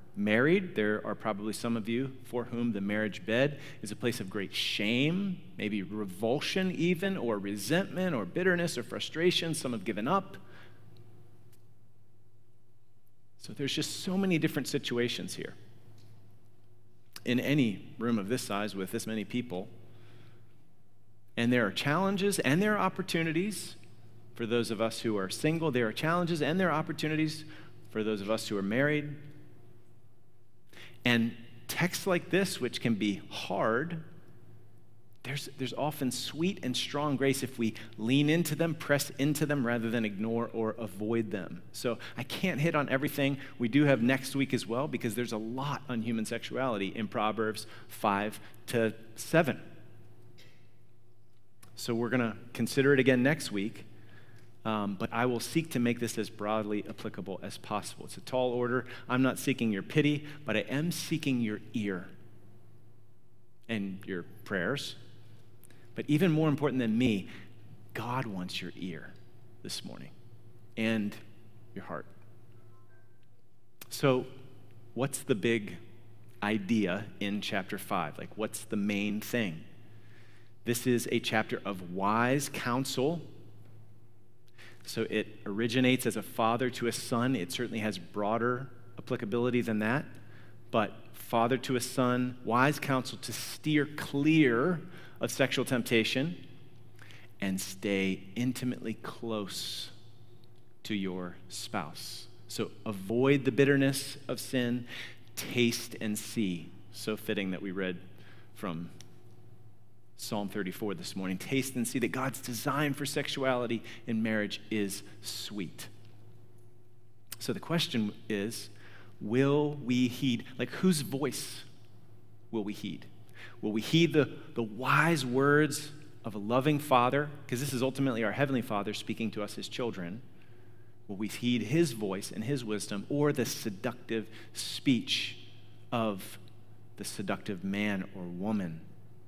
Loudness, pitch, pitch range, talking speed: -32 LUFS, 115 Hz, 110-130 Hz, 140 wpm